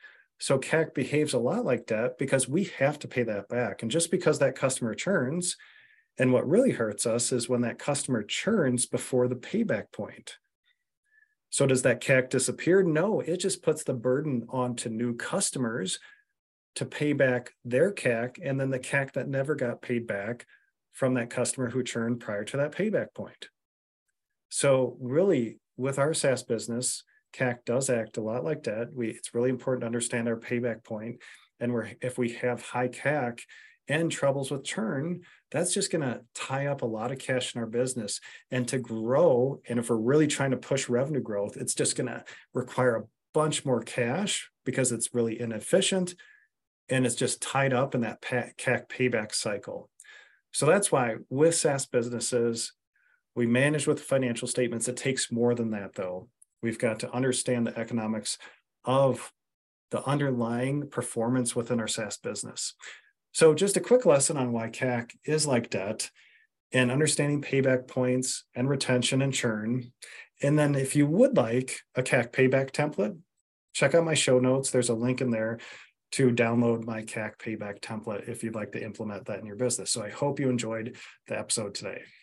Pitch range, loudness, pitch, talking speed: 120-145 Hz, -28 LUFS, 125 Hz, 180 wpm